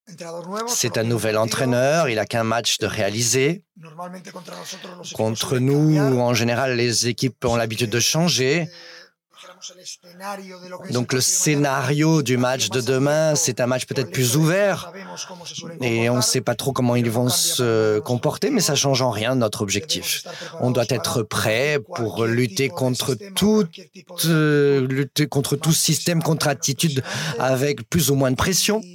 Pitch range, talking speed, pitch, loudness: 125-170 Hz, 150 wpm, 135 Hz, -20 LUFS